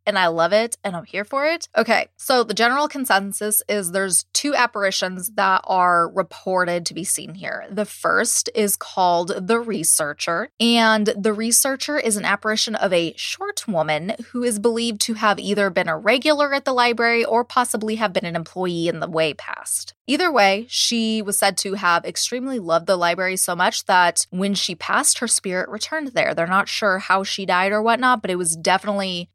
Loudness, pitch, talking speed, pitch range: -20 LUFS, 205 Hz, 195 wpm, 185-235 Hz